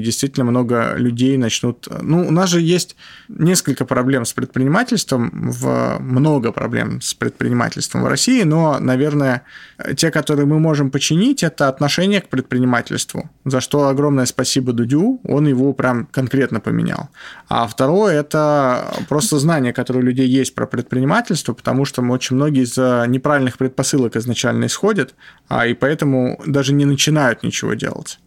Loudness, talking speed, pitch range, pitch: -17 LUFS, 145 wpm, 125-150 Hz, 135 Hz